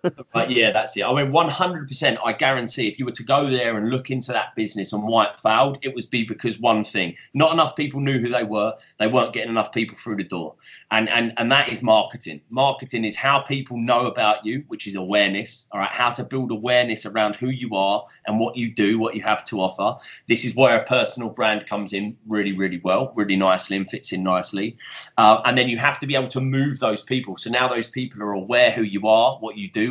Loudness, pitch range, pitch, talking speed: -21 LUFS, 105-130 Hz, 115 Hz, 245 wpm